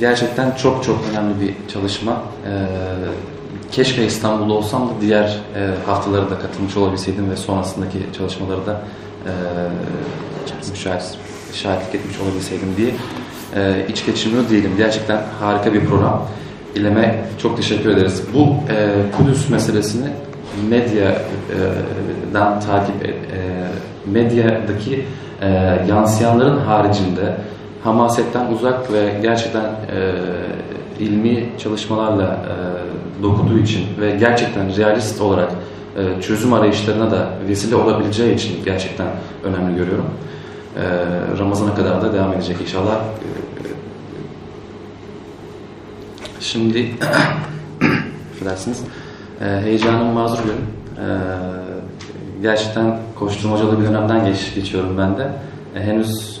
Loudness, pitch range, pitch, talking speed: -18 LUFS, 95-110 Hz, 105 Hz, 95 wpm